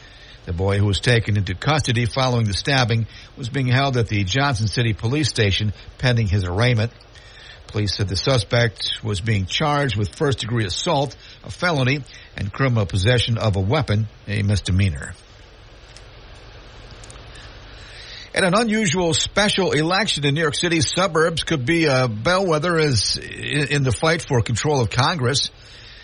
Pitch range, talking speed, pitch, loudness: 105-140 Hz, 150 wpm, 120 Hz, -20 LUFS